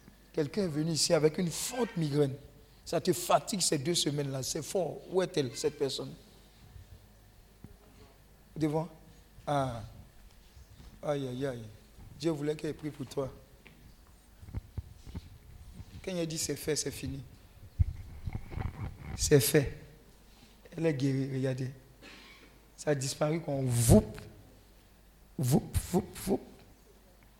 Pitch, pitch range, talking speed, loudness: 135 Hz, 105-155 Hz, 115 wpm, -32 LUFS